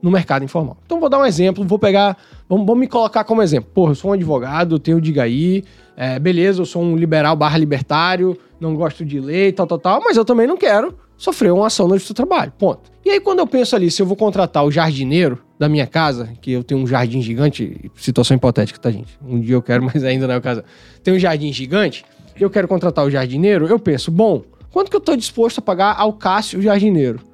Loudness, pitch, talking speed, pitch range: -16 LUFS, 170 Hz, 235 wpm, 140-200 Hz